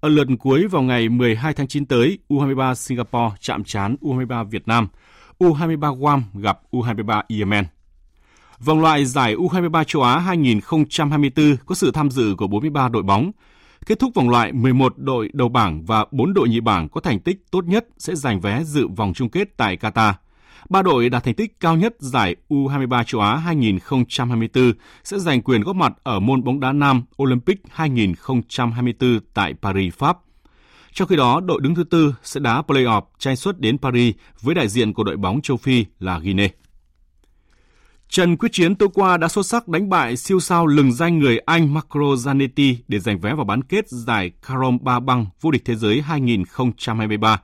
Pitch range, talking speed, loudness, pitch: 110-150 Hz, 185 wpm, -19 LUFS, 125 Hz